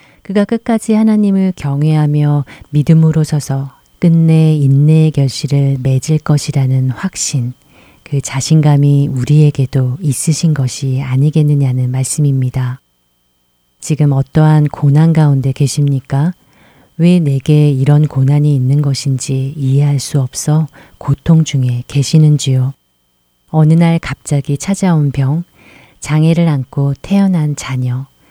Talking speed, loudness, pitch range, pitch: 260 characters per minute, -12 LUFS, 135-155 Hz, 145 Hz